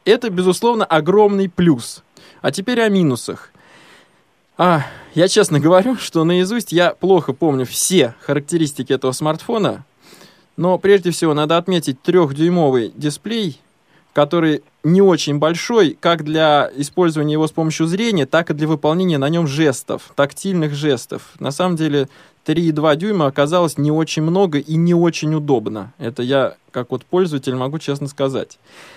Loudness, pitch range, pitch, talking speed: -17 LUFS, 145-180 Hz, 160 Hz, 145 wpm